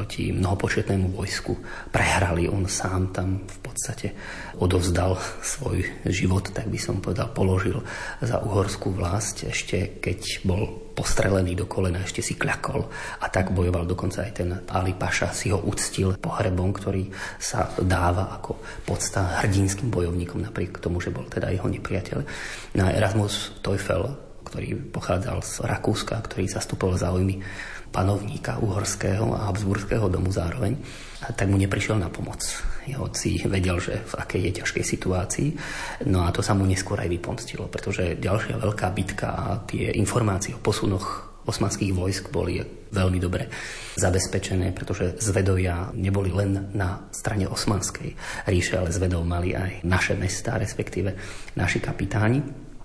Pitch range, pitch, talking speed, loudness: 95-110 Hz, 95 Hz, 145 wpm, -26 LUFS